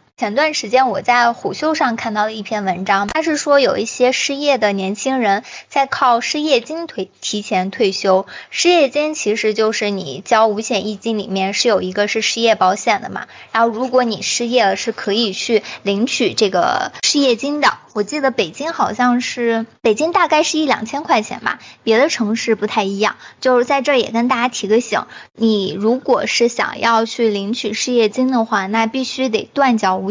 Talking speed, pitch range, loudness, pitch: 285 characters per minute, 210-260 Hz, -16 LUFS, 230 Hz